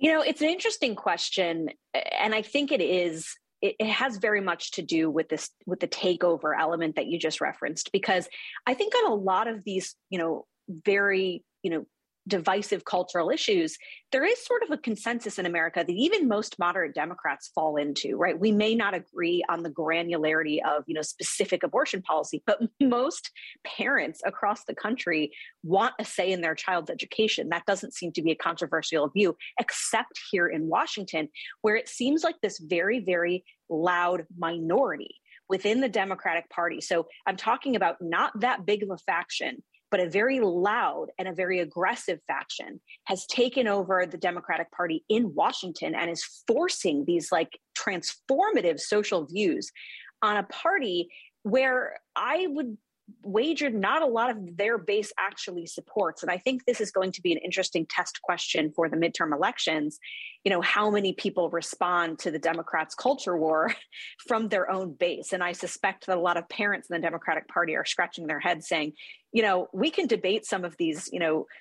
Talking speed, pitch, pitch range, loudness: 185 wpm, 185 Hz, 170-220 Hz, -27 LUFS